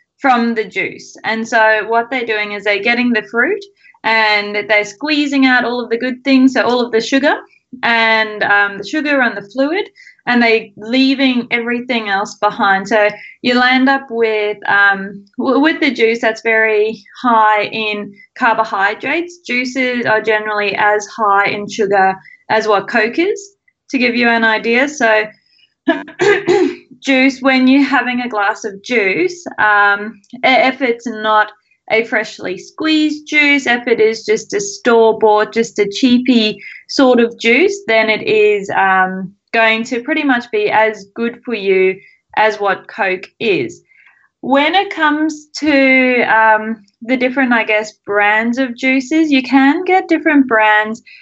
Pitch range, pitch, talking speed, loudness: 215-275 Hz, 235 Hz, 155 wpm, -13 LUFS